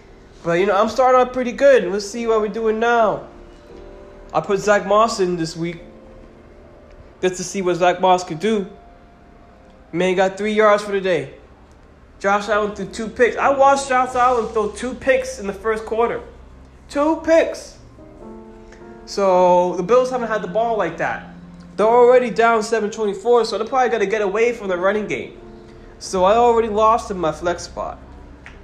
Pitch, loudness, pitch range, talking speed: 210 Hz, -18 LUFS, 180-230 Hz, 180 wpm